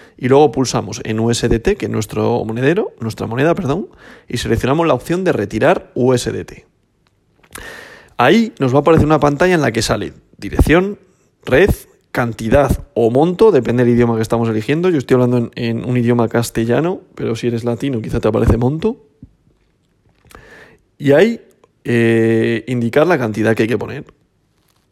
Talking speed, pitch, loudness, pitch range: 160 wpm, 120 Hz, -15 LUFS, 115-145 Hz